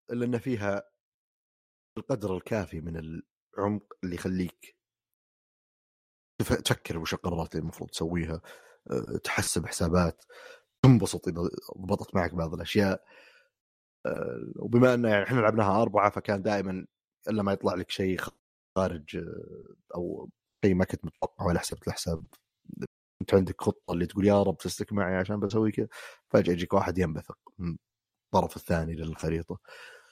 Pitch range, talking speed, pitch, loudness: 85-105 Hz, 130 wpm, 95 Hz, -29 LUFS